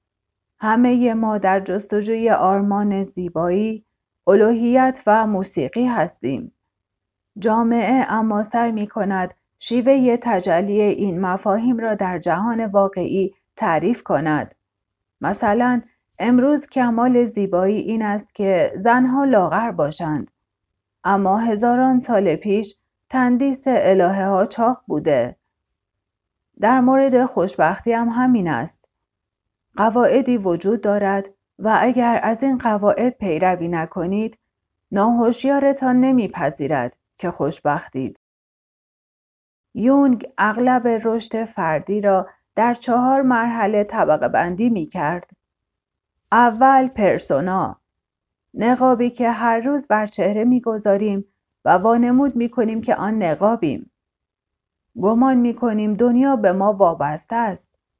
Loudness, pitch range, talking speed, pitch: -18 LUFS, 185-240 Hz, 100 wpm, 215 Hz